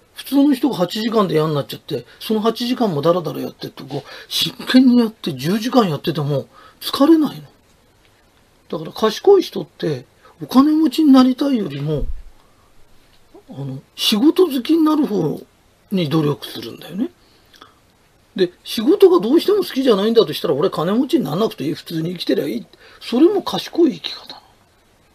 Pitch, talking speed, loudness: 225 Hz, 330 characters per minute, -17 LUFS